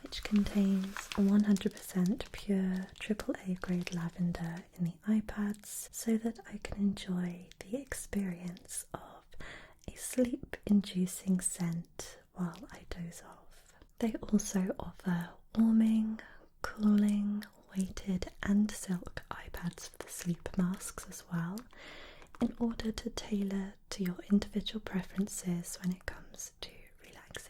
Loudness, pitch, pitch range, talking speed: -35 LUFS, 195 Hz, 180-215 Hz, 115 wpm